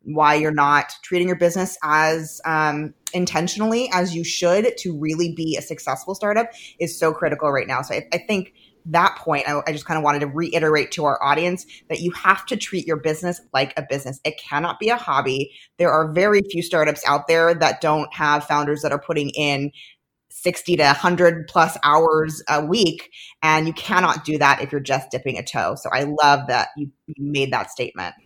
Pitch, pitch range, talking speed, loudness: 155 Hz, 145-175 Hz, 205 wpm, -20 LUFS